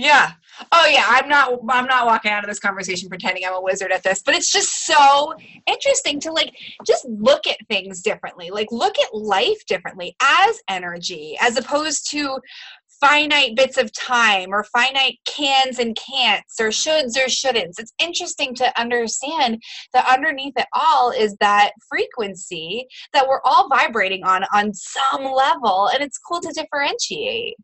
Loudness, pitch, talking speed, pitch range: -18 LUFS, 260 Hz, 165 wpm, 215-295 Hz